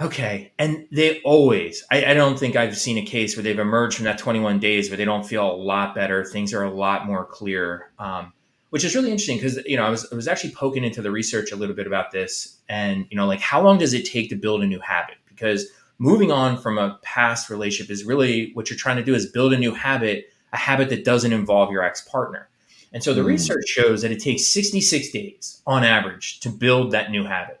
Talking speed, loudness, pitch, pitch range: 245 wpm, -21 LUFS, 110 Hz, 100-130 Hz